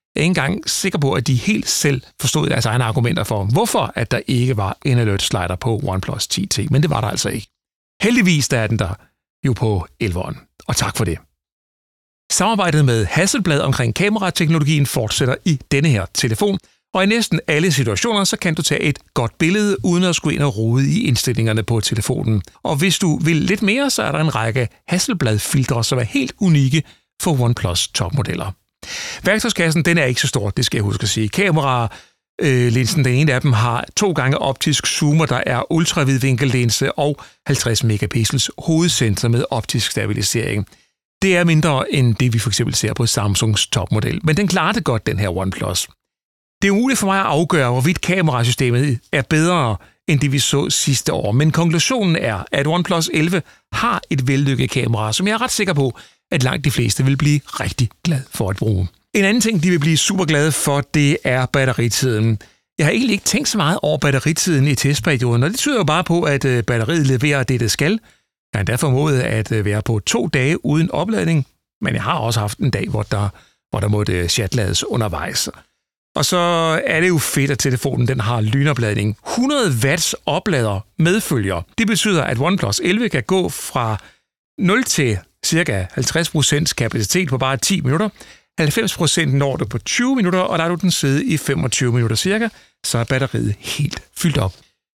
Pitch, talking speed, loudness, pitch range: 140 Hz, 195 wpm, -17 LUFS, 115-165 Hz